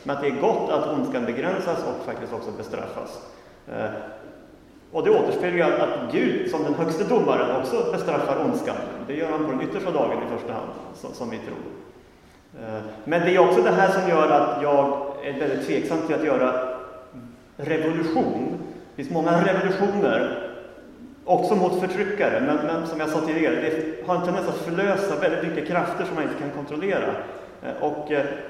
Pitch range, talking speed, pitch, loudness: 145-190 Hz, 175 wpm, 165 Hz, -24 LUFS